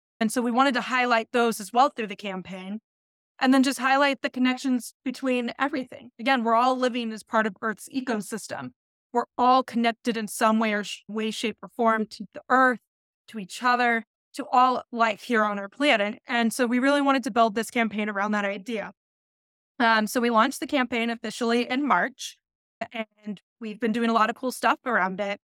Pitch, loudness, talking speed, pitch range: 235 Hz, -24 LUFS, 205 wpm, 220-255 Hz